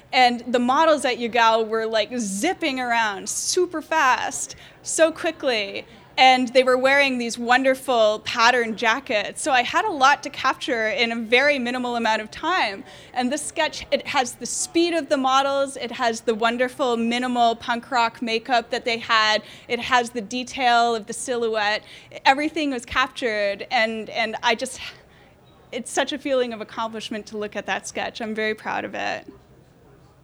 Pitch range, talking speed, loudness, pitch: 230-270 Hz, 170 wpm, -21 LUFS, 245 Hz